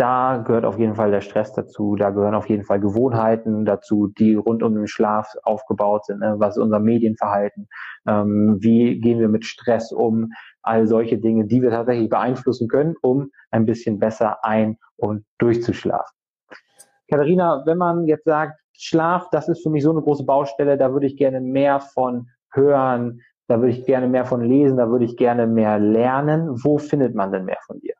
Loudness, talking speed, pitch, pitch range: -19 LUFS, 195 wpm, 120 Hz, 110-135 Hz